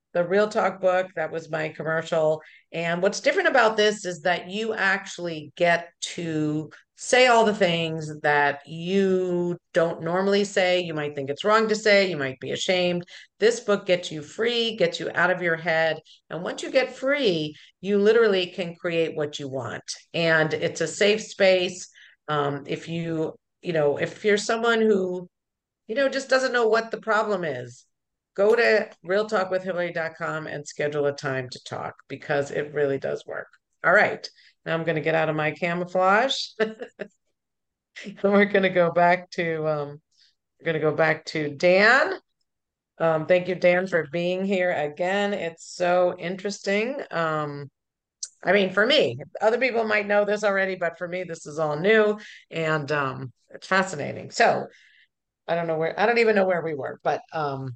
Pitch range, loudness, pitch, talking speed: 155-200 Hz, -23 LUFS, 175 Hz, 175 wpm